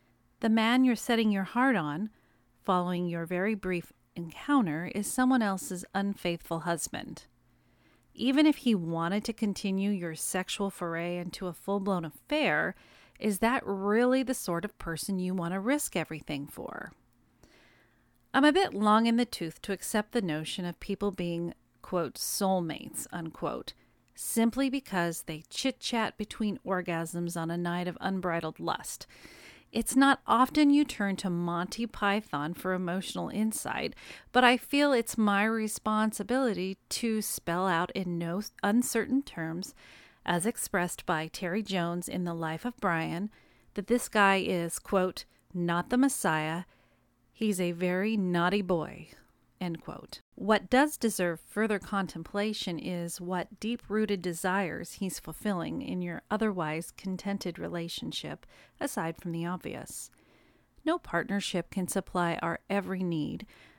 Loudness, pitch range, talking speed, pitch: -30 LUFS, 175-220 Hz, 140 wpm, 195 Hz